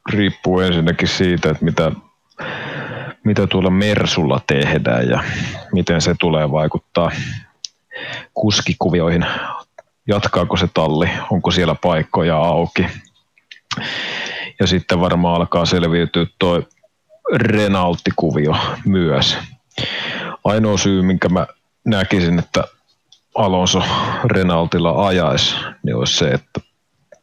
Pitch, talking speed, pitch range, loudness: 90 Hz, 95 wpm, 85-100 Hz, -17 LUFS